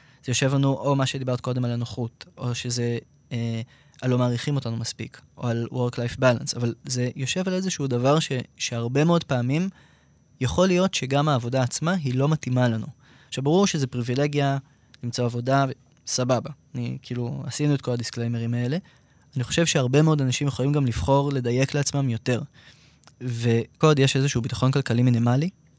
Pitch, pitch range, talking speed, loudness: 130 Hz, 120-145 Hz, 165 wpm, -24 LUFS